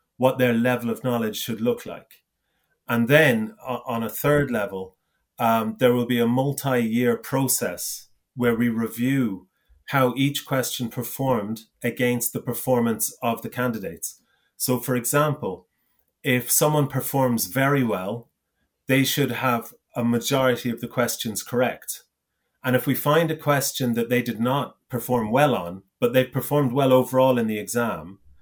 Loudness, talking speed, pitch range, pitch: -23 LUFS, 155 wpm, 115-130 Hz, 125 Hz